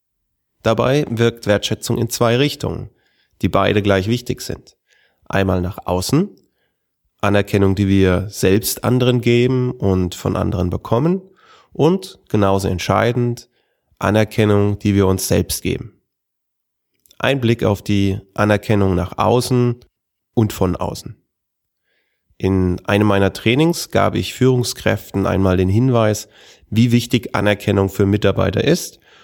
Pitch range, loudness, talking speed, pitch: 95-120 Hz, -17 LUFS, 120 wpm, 105 Hz